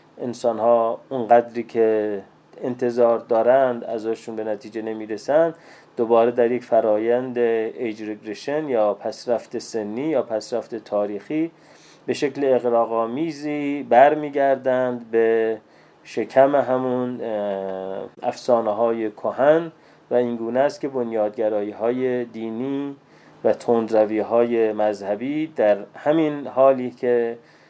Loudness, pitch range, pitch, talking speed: -22 LUFS, 110-130 Hz, 120 Hz, 110 wpm